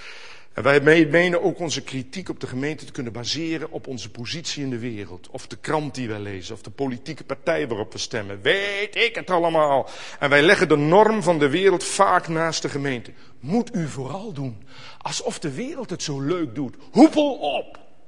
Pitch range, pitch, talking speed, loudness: 130-175 Hz, 150 Hz, 200 wpm, -22 LUFS